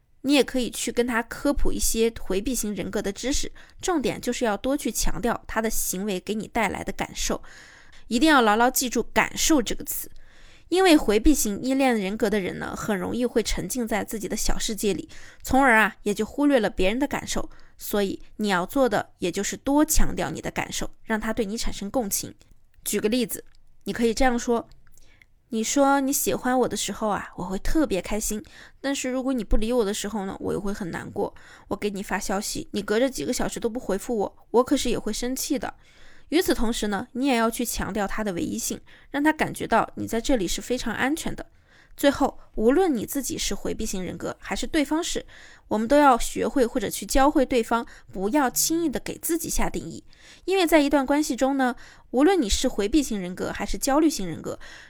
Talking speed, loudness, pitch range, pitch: 310 characters per minute, -25 LUFS, 210-270 Hz, 235 Hz